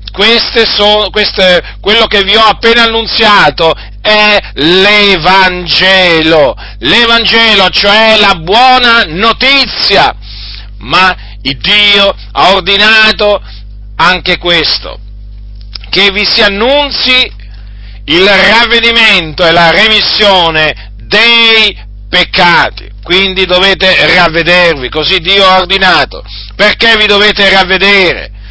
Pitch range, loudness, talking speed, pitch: 165-215 Hz, -5 LUFS, 95 wpm, 195 Hz